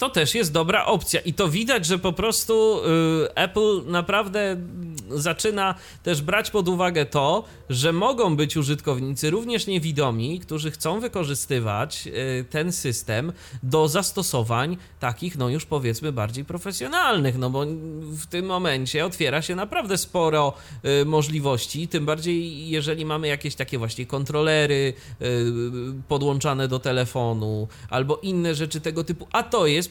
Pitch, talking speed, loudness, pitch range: 155 Hz, 140 wpm, -24 LUFS, 135-175 Hz